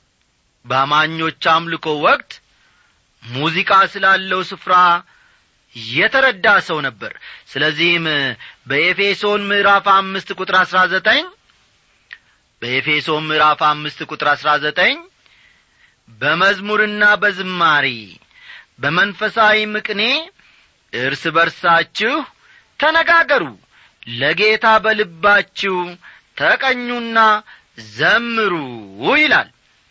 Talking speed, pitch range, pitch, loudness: 70 wpm, 155-215 Hz, 190 Hz, -15 LUFS